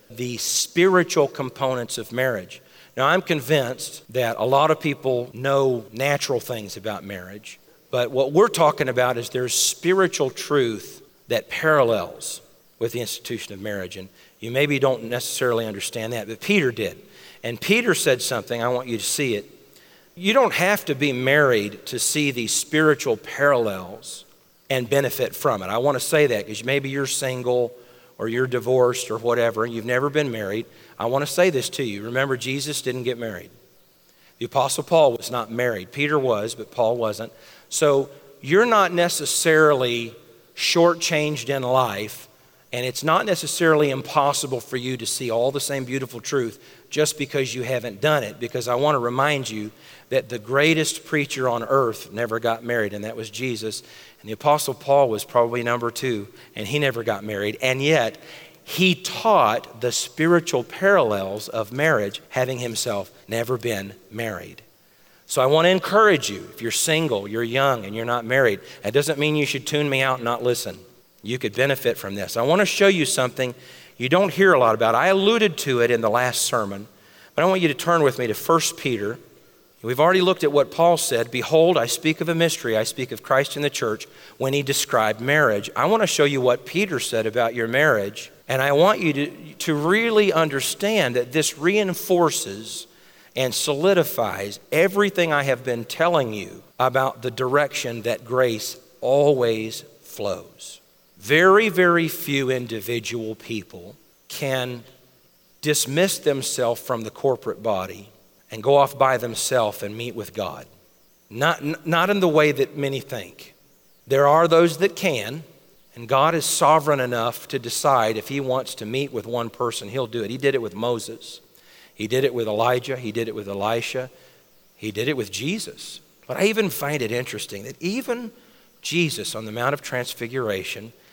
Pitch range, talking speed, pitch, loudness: 115-150 Hz, 180 wpm, 130 Hz, -21 LUFS